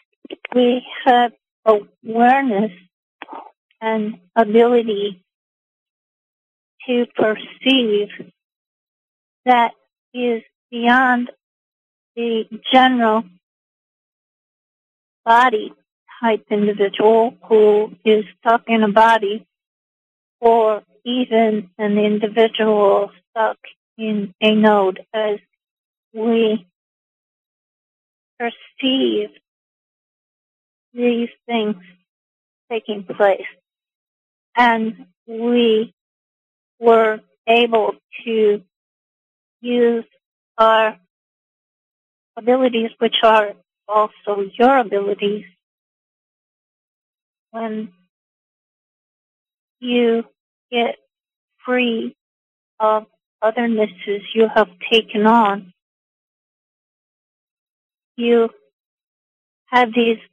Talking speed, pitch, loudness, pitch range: 60 wpm, 225 Hz, -17 LUFS, 210-235 Hz